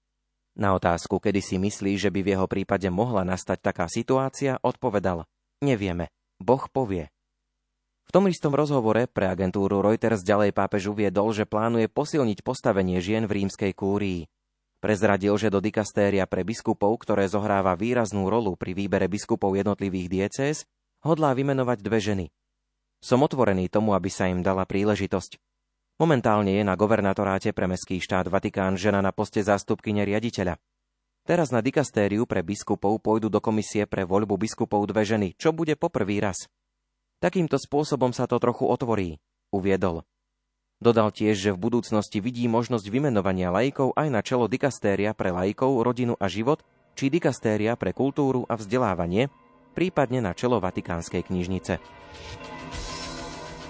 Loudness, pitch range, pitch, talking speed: -25 LUFS, 95-115 Hz, 105 Hz, 145 wpm